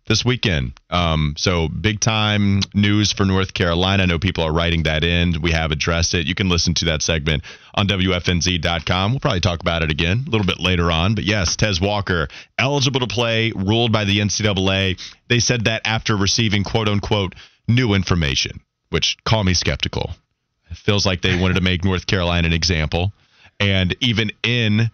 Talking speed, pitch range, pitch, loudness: 190 wpm, 85-110 Hz, 95 Hz, -18 LUFS